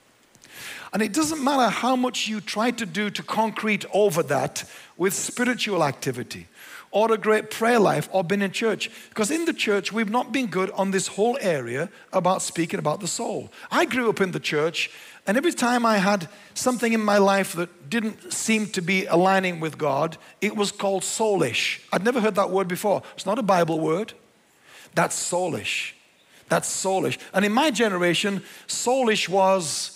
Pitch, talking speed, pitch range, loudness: 205 Hz, 180 wpm, 185-230 Hz, -23 LUFS